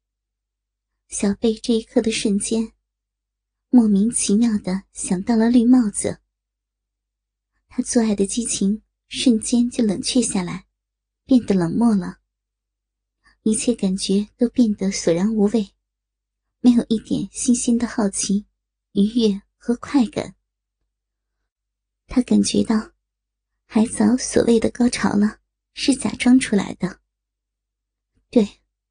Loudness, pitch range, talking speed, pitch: -20 LUFS, 205-240 Hz, 170 characters per minute, 225 Hz